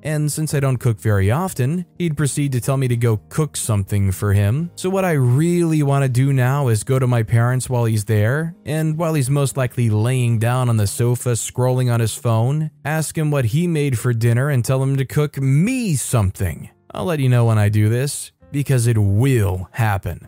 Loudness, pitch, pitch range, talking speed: -19 LUFS, 125 Hz, 115-145 Hz, 220 wpm